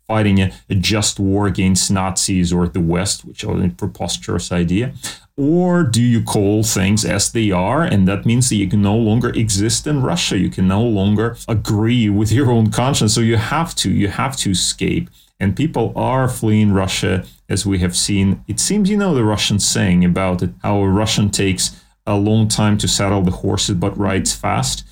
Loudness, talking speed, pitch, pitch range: -16 LUFS, 200 wpm, 105 Hz, 95-115 Hz